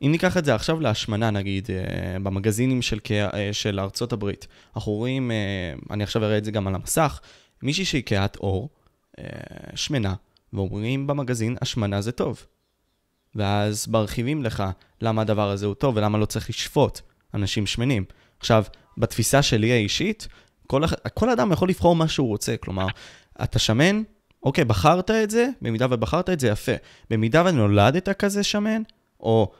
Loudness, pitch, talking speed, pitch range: -23 LUFS, 115 Hz, 160 wpm, 105-140 Hz